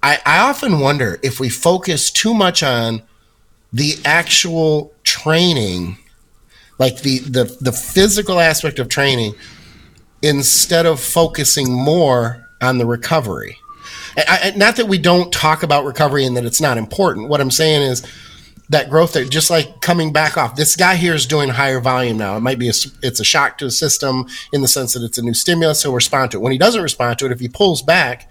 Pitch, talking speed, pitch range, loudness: 140 Hz, 195 wpm, 125-165 Hz, -14 LUFS